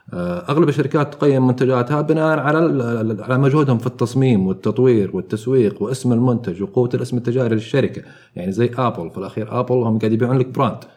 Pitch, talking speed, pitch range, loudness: 125 Hz, 160 wpm, 115-135 Hz, -18 LUFS